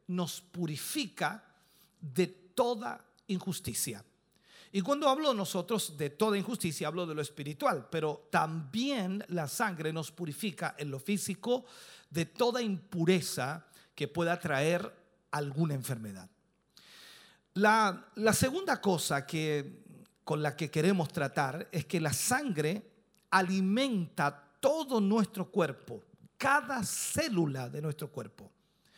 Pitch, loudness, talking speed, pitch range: 180 Hz, -33 LUFS, 120 wpm, 155-210 Hz